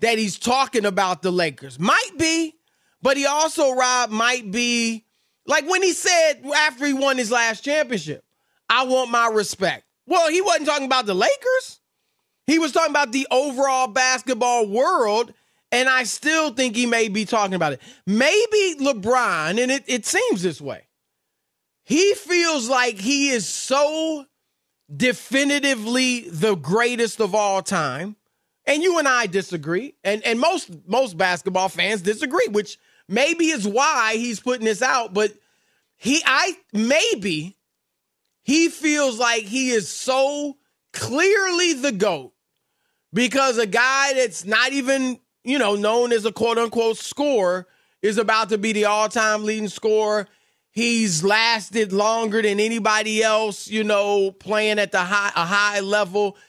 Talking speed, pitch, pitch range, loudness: 150 wpm, 235 Hz, 210-275 Hz, -20 LUFS